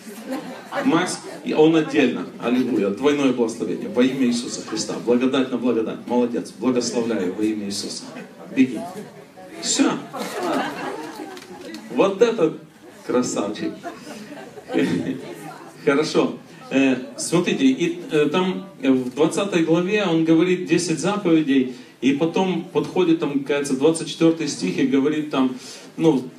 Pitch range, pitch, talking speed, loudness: 130-185 Hz, 155 Hz, 100 wpm, -21 LUFS